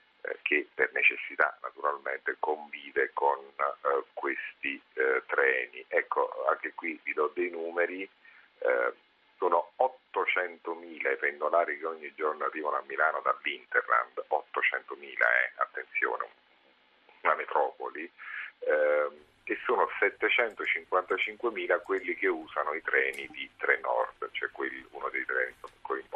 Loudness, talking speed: -30 LUFS, 120 wpm